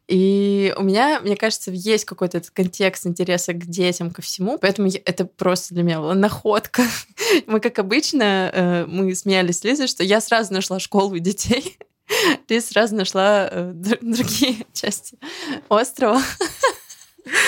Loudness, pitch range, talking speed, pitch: -20 LUFS, 185-235 Hz, 135 wpm, 200 Hz